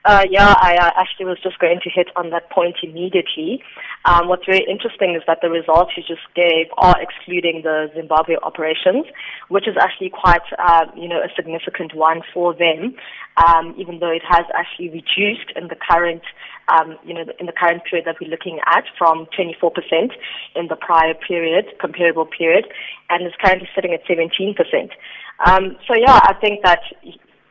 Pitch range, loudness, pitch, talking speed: 165-185 Hz, -16 LUFS, 175 Hz, 190 wpm